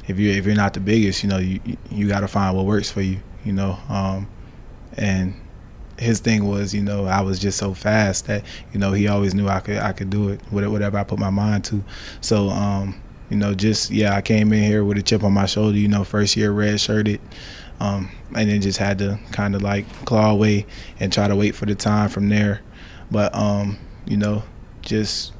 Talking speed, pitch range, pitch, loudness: 230 wpm, 100-105 Hz, 100 Hz, -20 LUFS